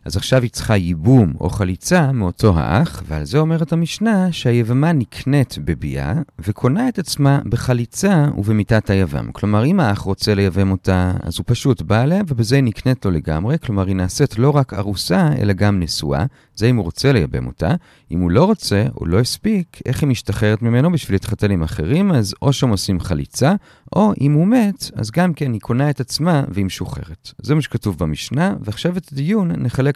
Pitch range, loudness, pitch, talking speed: 95-145 Hz, -17 LUFS, 120 Hz, 190 wpm